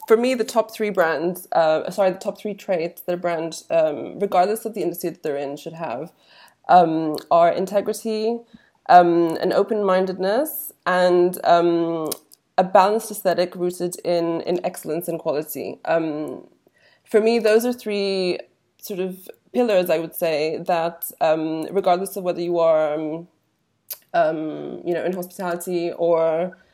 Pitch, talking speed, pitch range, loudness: 180 Hz, 155 wpm, 165-205 Hz, -21 LUFS